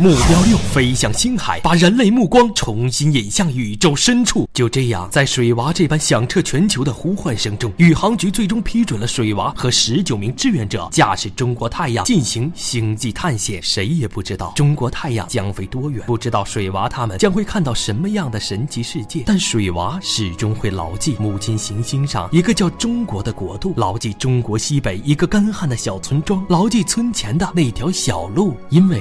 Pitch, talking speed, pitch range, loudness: 135 Hz, 300 characters per minute, 110-180 Hz, -17 LUFS